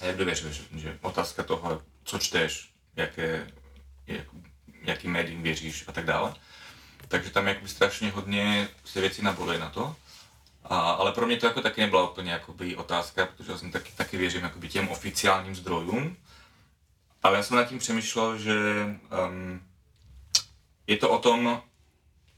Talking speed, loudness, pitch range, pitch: 155 wpm, -28 LUFS, 80-100 Hz, 90 Hz